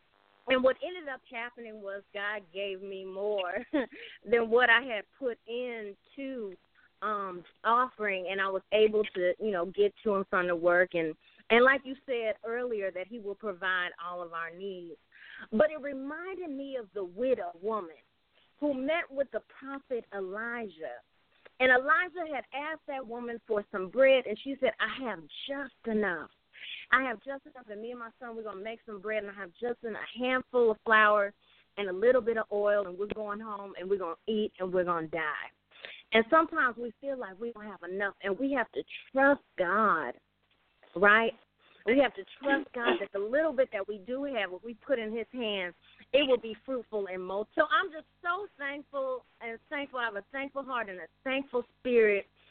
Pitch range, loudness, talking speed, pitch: 200-260 Hz, -31 LUFS, 200 wpm, 225 Hz